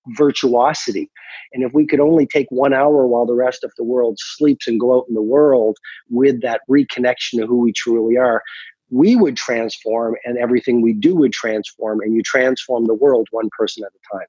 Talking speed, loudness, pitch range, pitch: 205 wpm, -16 LUFS, 115-135 Hz, 125 Hz